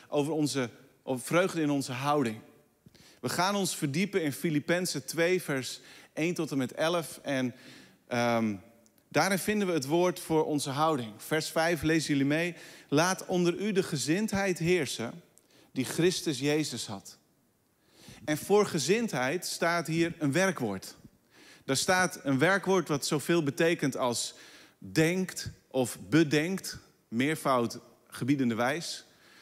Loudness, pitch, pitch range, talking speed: -29 LUFS, 155 Hz, 130-175 Hz, 135 wpm